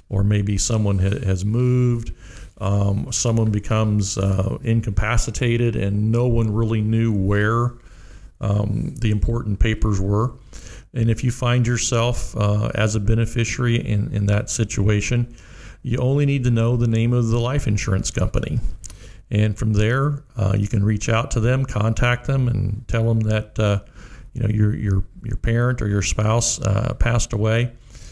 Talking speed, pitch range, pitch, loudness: 160 wpm, 105-120 Hz, 110 Hz, -21 LUFS